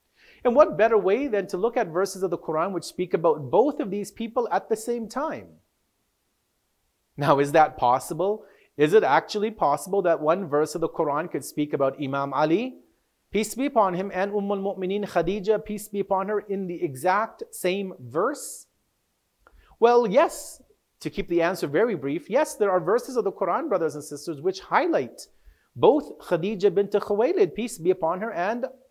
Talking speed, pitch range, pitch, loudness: 185 wpm, 170-220 Hz, 195 Hz, -24 LUFS